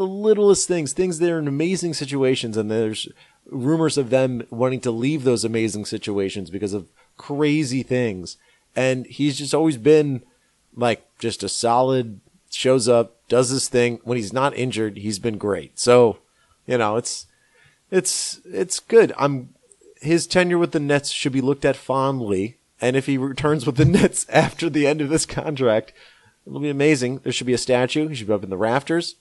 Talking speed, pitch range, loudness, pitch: 185 wpm, 120-155 Hz, -21 LUFS, 130 Hz